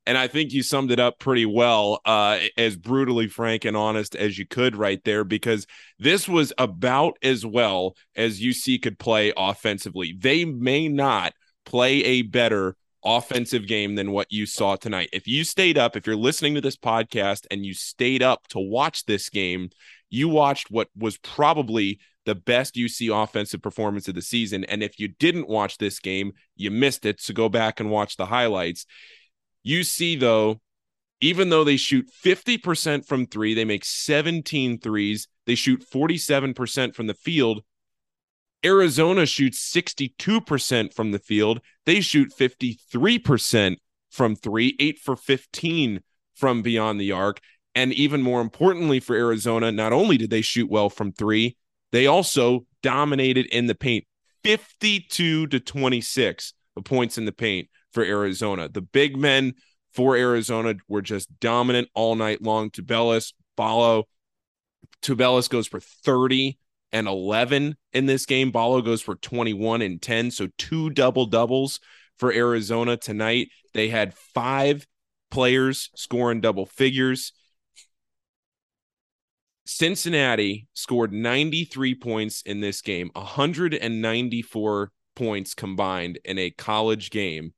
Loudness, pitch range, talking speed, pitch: -23 LUFS, 105-135 Hz, 145 wpm, 115 Hz